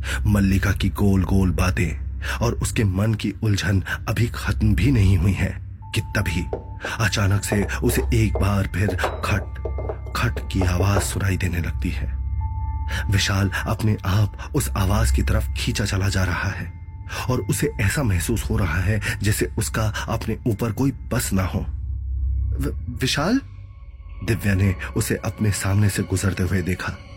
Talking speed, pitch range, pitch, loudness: 155 wpm, 90-105 Hz, 95 Hz, -23 LUFS